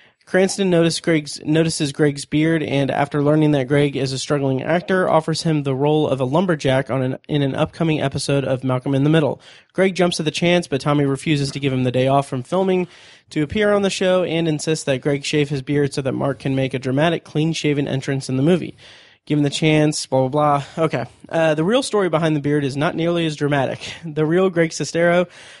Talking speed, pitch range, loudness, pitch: 225 wpm, 140-165 Hz, -19 LUFS, 150 Hz